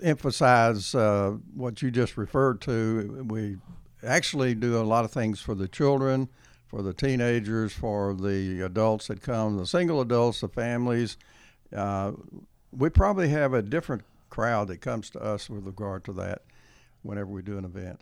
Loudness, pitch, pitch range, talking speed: -27 LUFS, 110 Hz, 100-125 Hz, 165 wpm